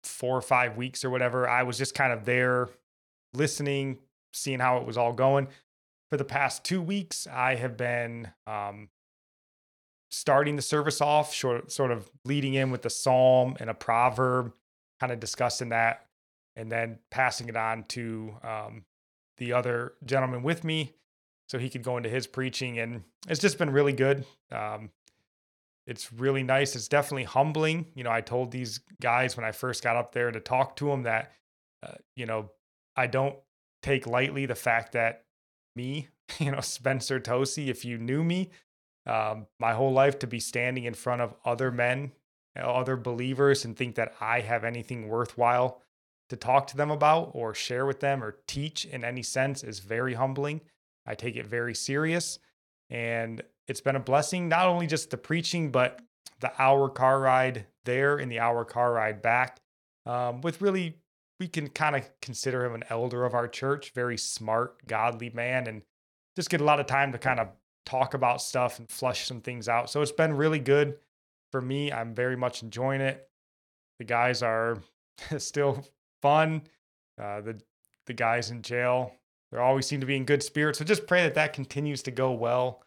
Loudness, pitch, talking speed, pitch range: -28 LUFS, 125 Hz, 185 wpm, 115-140 Hz